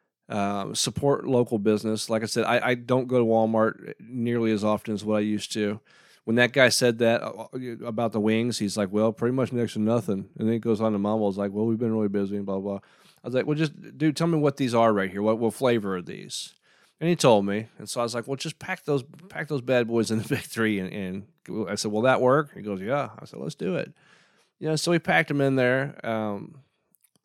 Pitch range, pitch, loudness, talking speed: 105-130 Hz, 115 Hz, -25 LUFS, 260 wpm